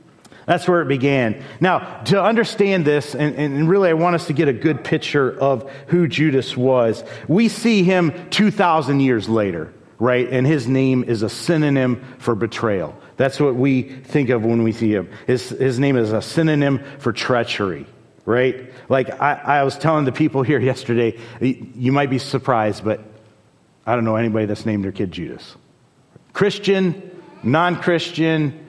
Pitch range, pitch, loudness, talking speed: 120-160 Hz, 135 Hz, -19 LUFS, 170 wpm